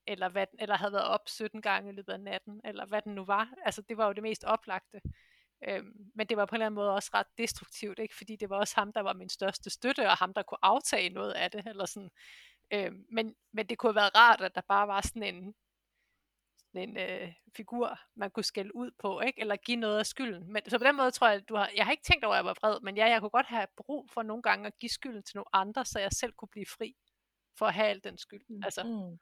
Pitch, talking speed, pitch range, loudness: 215 Hz, 275 wpm, 200-225 Hz, -31 LUFS